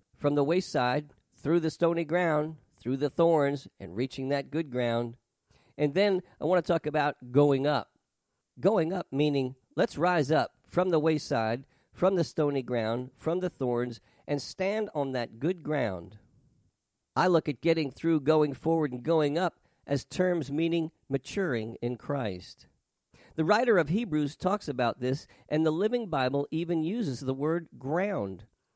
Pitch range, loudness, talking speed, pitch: 125-165 Hz, -29 LUFS, 165 wpm, 145 Hz